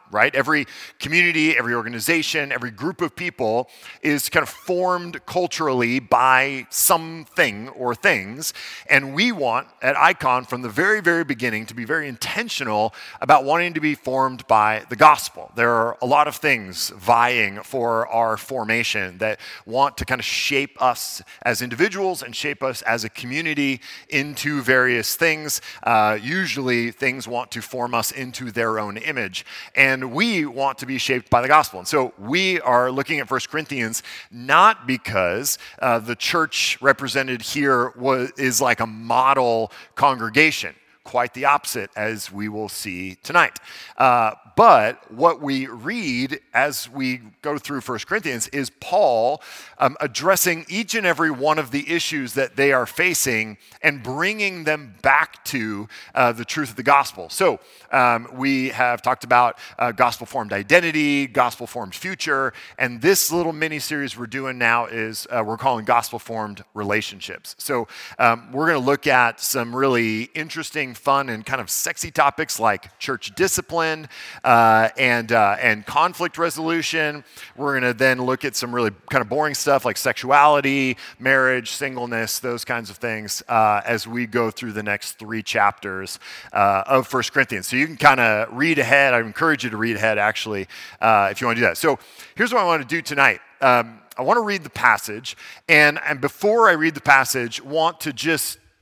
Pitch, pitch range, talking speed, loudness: 130 Hz, 115-150 Hz, 175 wpm, -20 LUFS